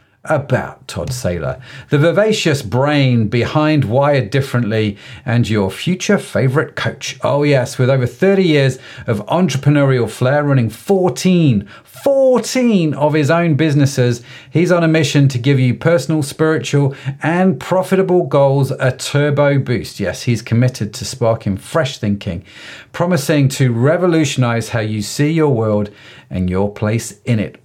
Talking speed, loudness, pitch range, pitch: 140 wpm, -15 LUFS, 120-160 Hz, 135 Hz